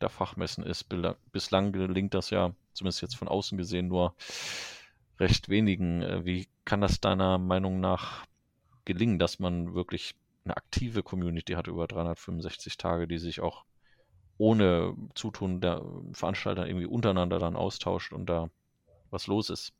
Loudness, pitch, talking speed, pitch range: -31 LUFS, 90 Hz, 145 wpm, 85-95 Hz